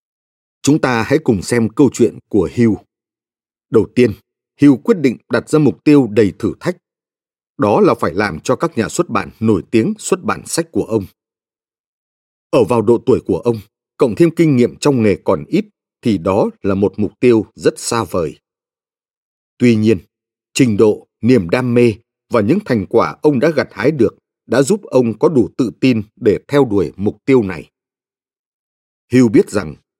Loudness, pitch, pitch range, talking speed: -15 LUFS, 120 Hz, 110-140 Hz, 185 wpm